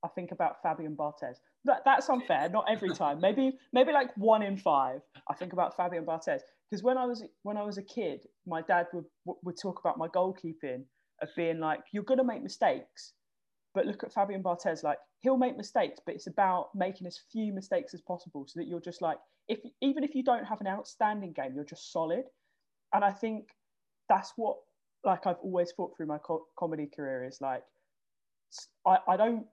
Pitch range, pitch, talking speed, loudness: 165-225 Hz, 185 Hz, 205 wpm, -32 LUFS